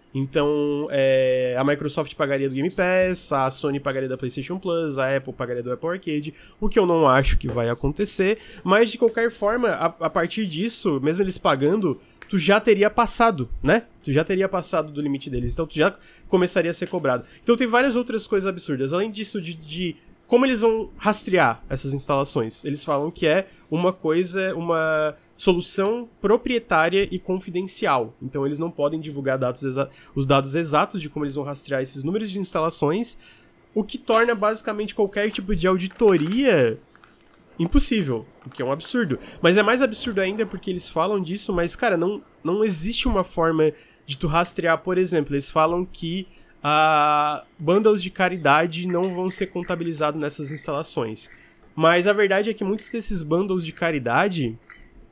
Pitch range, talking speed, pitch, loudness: 150-205 Hz, 175 wpm, 175 Hz, -22 LUFS